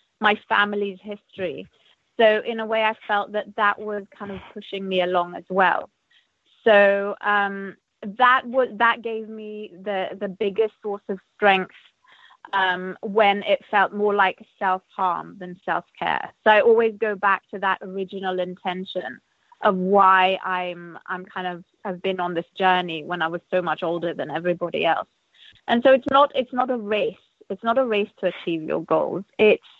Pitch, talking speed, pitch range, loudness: 200 Hz, 180 wpm, 185-220 Hz, -22 LUFS